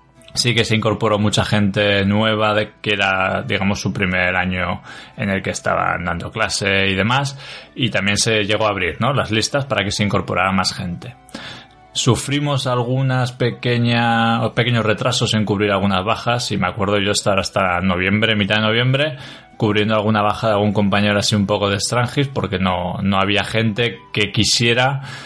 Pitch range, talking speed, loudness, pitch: 100-120 Hz, 175 wpm, -17 LUFS, 105 Hz